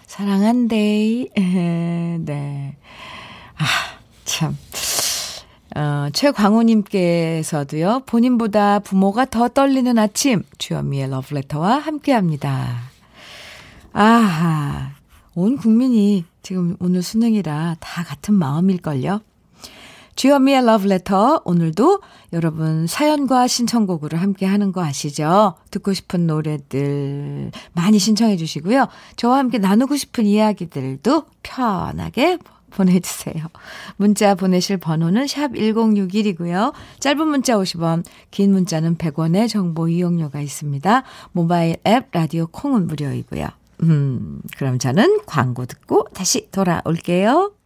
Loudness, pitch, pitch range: -18 LUFS, 190 Hz, 160-225 Hz